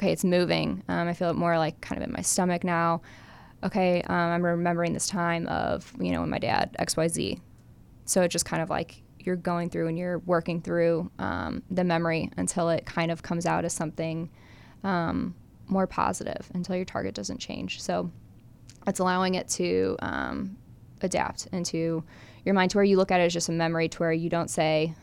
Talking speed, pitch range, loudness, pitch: 210 wpm, 160-180 Hz, -28 LUFS, 170 Hz